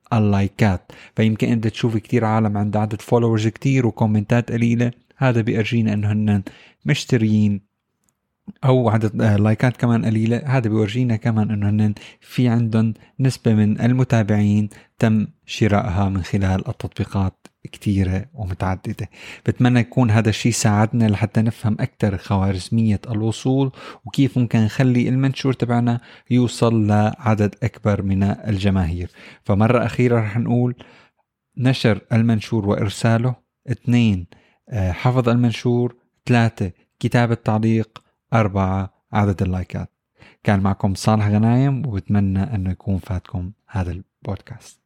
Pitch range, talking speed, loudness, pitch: 105-120 Hz, 110 wpm, -20 LUFS, 110 Hz